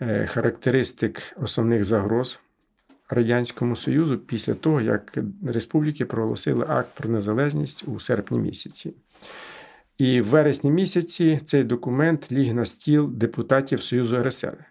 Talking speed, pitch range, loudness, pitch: 115 wpm, 115-145 Hz, -23 LUFS, 125 Hz